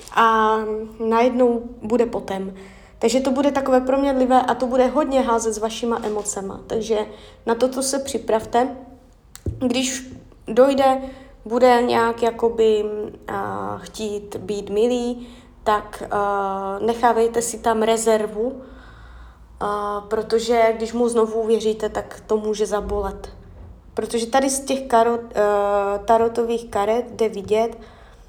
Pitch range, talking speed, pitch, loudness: 215-245 Hz, 120 wpm, 230 Hz, -21 LUFS